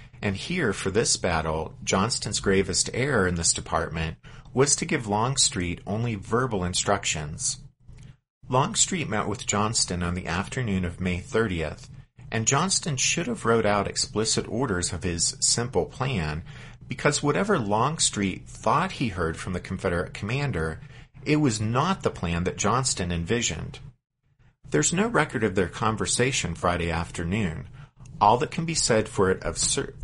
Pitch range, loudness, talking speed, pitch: 95-135 Hz, -25 LUFS, 150 wpm, 120 Hz